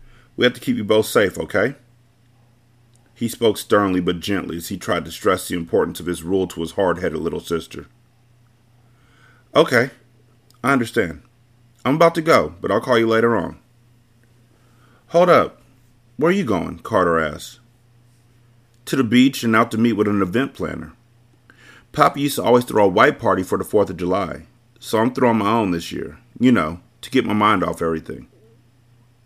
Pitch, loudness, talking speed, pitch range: 120 Hz, -19 LUFS, 185 wpm, 110-120 Hz